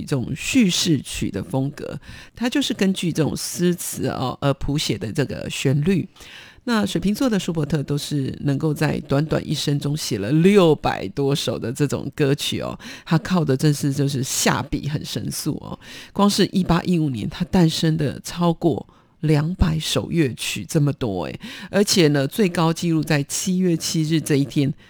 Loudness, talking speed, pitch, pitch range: -21 LUFS, 255 characters per minute, 155 Hz, 140-175 Hz